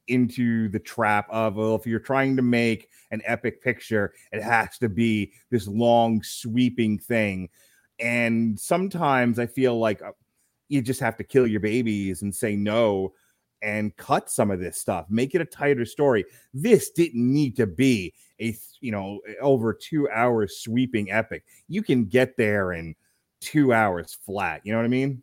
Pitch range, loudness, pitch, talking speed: 105-125 Hz, -24 LUFS, 115 Hz, 175 wpm